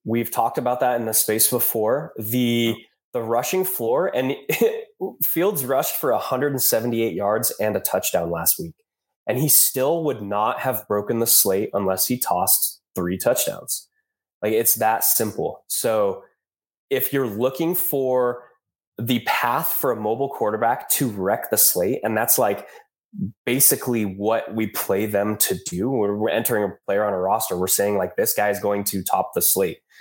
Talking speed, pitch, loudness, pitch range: 170 wpm, 120 Hz, -21 LUFS, 105-150 Hz